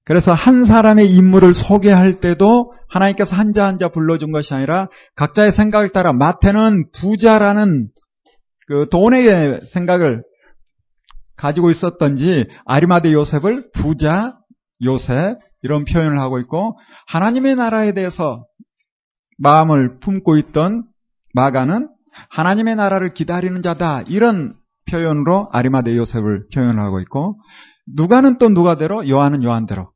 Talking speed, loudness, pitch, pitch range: 295 characters per minute, -14 LUFS, 180 Hz, 150-210 Hz